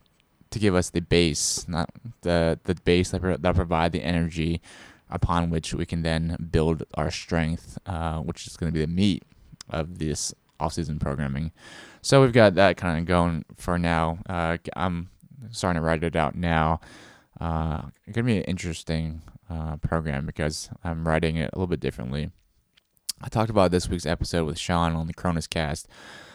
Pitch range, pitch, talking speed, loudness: 80-90 Hz, 85 Hz, 180 wpm, -26 LUFS